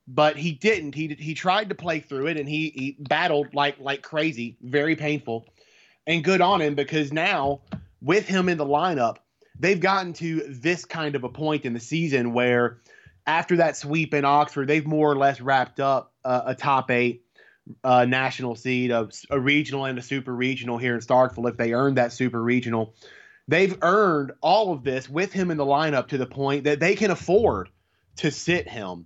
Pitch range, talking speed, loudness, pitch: 125-155 Hz, 200 wpm, -23 LUFS, 140 Hz